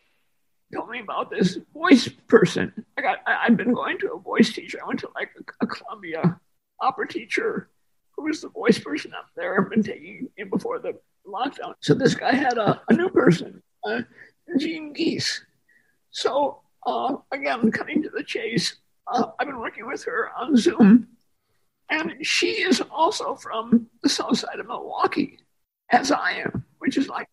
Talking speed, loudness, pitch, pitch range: 180 wpm, -23 LUFS, 295 Hz, 230-370 Hz